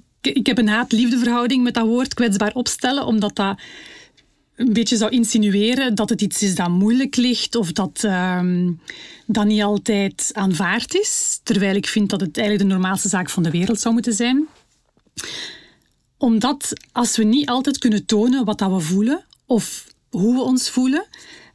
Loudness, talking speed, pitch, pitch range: -19 LUFS, 170 wpm, 225 Hz, 200-250 Hz